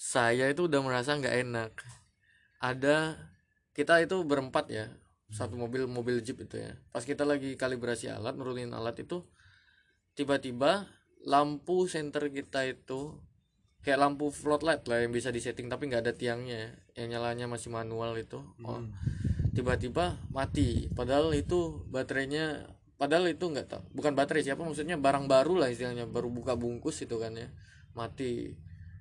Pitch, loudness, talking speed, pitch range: 125 Hz, -32 LUFS, 145 wpm, 115-145 Hz